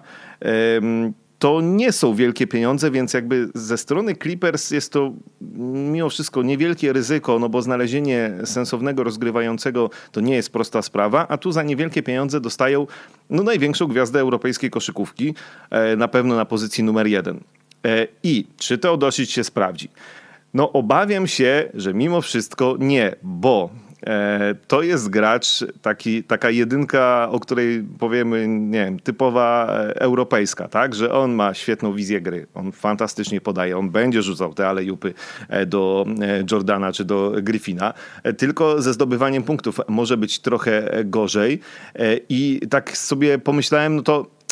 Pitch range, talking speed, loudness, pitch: 110-140 Hz, 140 wpm, -20 LUFS, 125 Hz